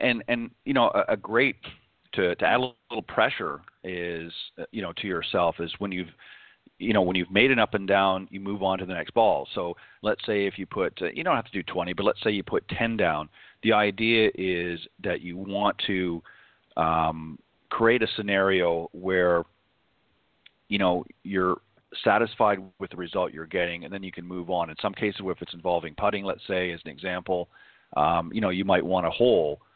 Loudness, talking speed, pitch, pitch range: -26 LUFS, 210 wpm, 95 Hz, 85-100 Hz